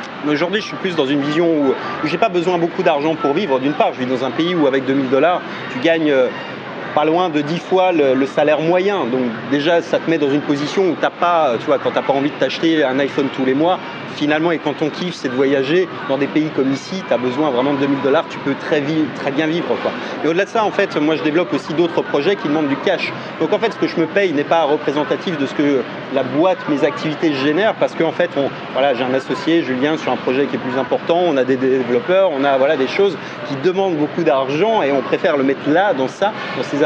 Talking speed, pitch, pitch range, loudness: 270 wpm, 150 Hz, 140-170 Hz, -17 LUFS